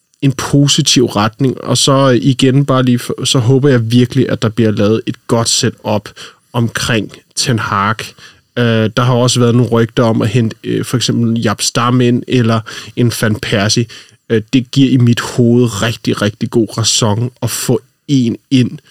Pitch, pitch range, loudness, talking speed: 120 Hz, 115-130 Hz, -12 LUFS, 170 wpm